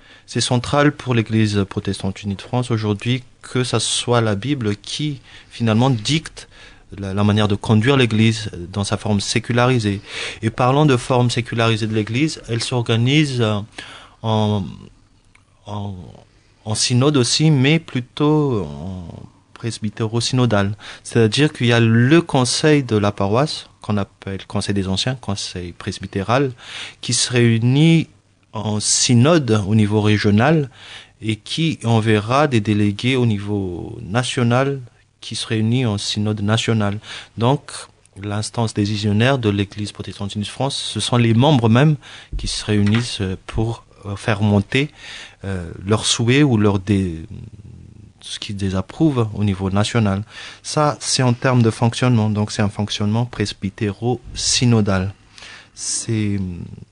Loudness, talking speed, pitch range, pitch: -18 LUFS, 135 wpm, 105-125 Hz, 110 Hz